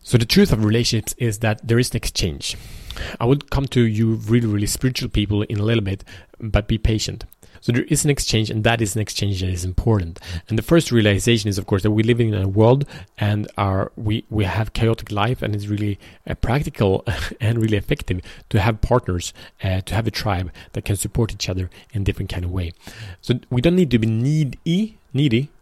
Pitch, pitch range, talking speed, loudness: 110 Hz, 100-120 Hz, 220 wpm, -20 LUFS